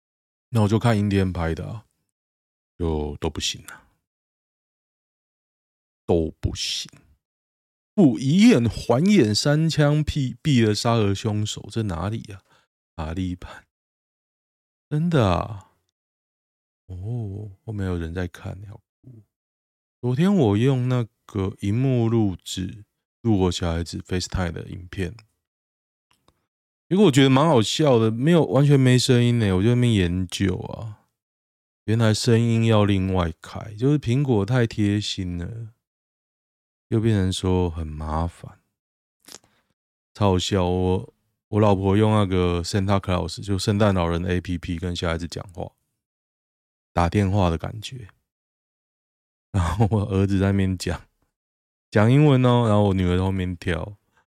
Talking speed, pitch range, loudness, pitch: 210 characters per minute, 85-115 Hz, -22 LUFS, 100 Hz